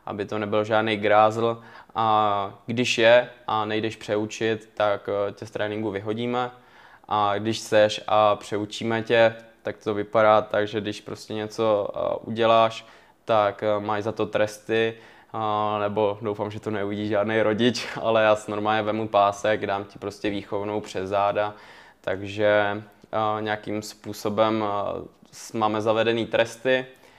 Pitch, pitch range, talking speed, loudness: 105 Hz, 105-110 Hz, 135 wpm, -24 LUFS